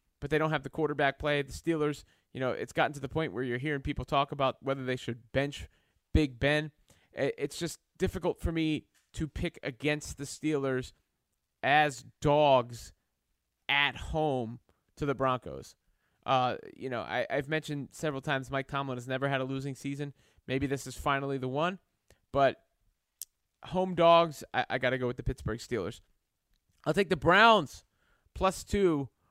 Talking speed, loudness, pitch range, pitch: 175 wpm, -31 LUFS, 130-155 Hz, 140 Hz